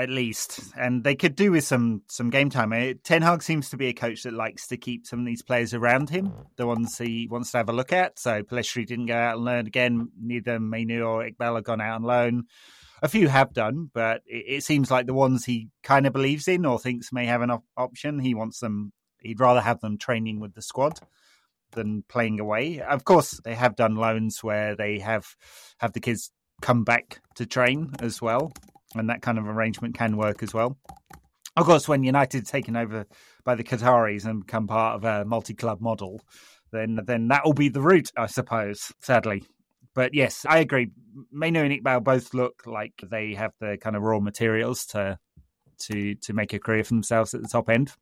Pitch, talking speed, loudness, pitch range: 120 Hz, 220 wpm, -25 LUFS, 110-125 Hz